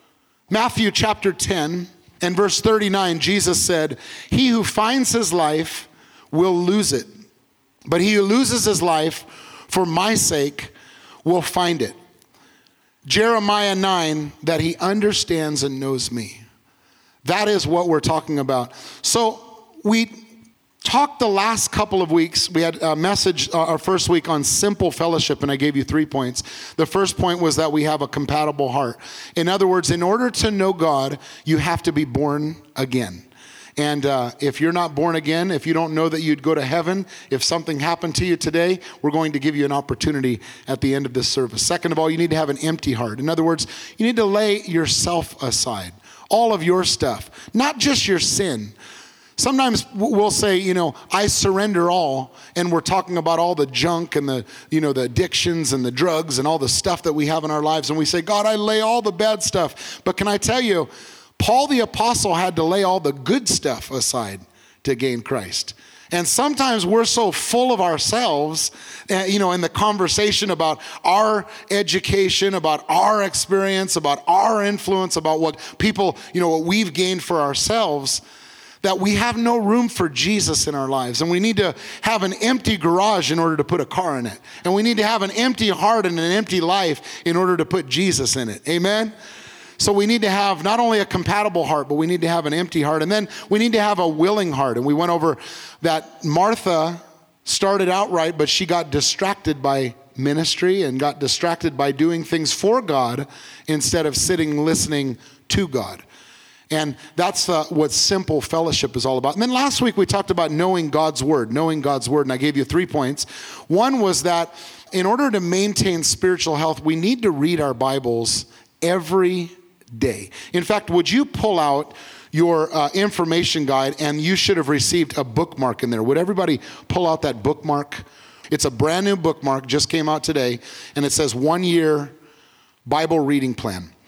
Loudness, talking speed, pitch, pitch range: -19 LUFS, 195 wpm, 165 Hz, 150-195 Hz